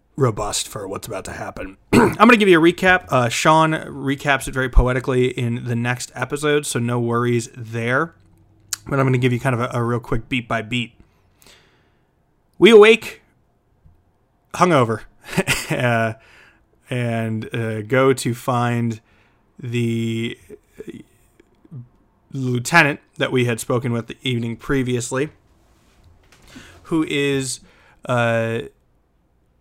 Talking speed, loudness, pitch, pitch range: 130 wpm, -19 LUFS, 120 Hz, 115-135 Hz